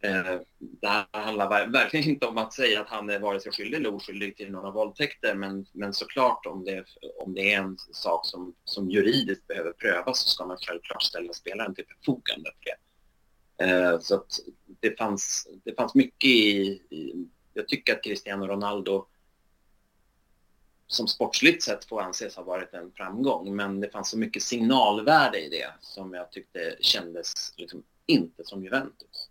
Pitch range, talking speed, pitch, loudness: 95-105 Hz, 165 wpm, 100 Hz, -26 LUFS